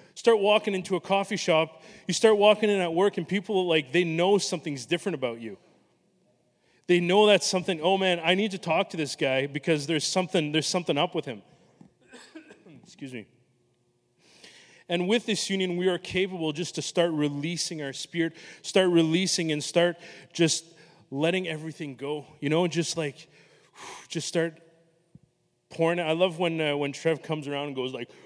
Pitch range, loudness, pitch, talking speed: 155-185 Hz, -26 LUFS, 170 Hz, 180 wpm